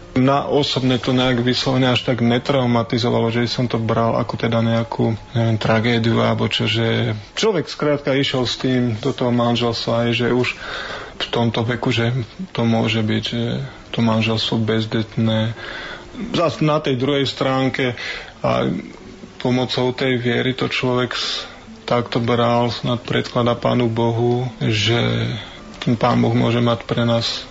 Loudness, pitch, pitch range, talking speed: -19 LUFS, 120 Hz, 115-130 Hz, 145 wpm